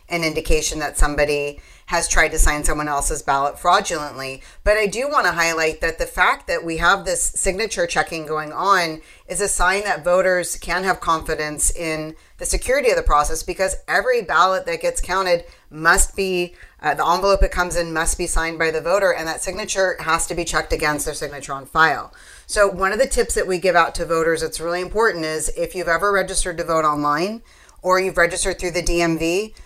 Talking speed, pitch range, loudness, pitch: 205 wpm, 160-190 Hz, -20 LUFS, 170 Hz